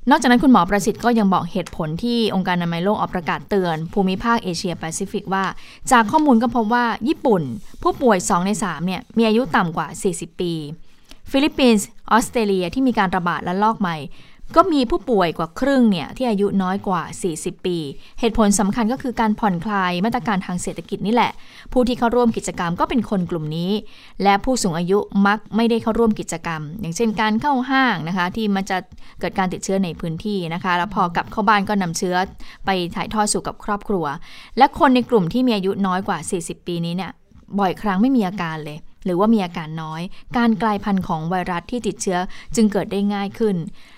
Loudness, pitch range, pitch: -20 LUFS, 180-225 Hz, 200 Hz